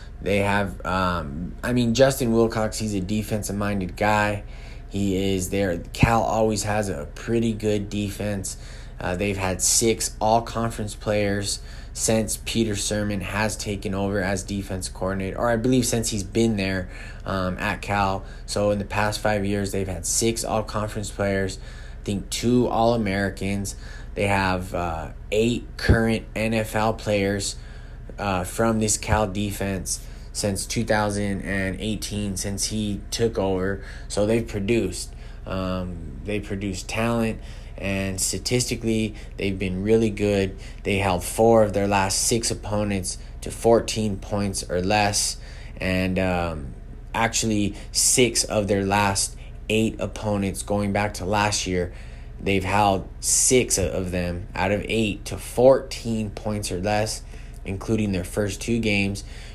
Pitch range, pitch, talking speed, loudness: 95-110 Hz, 100 Hz, 145 wpm, -24 LUFS